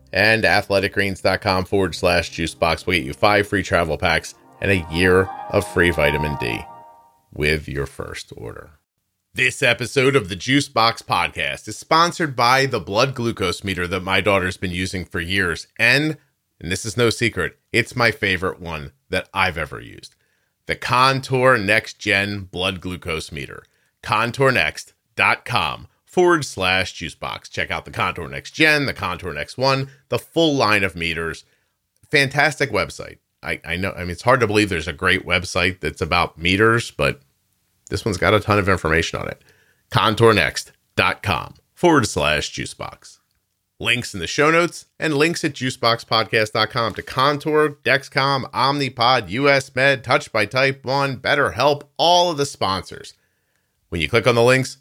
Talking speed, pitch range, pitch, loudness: 165 wpm, 95-135 Hz, 105 Hz, -19 LUFS